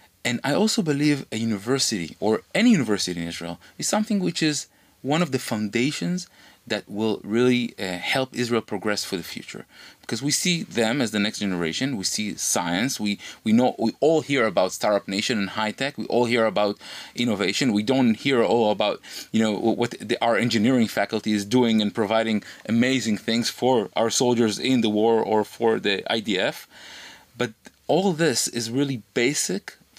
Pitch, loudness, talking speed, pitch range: 115 Hz, -23 LUFS, 185 wpm, 105-135 Hz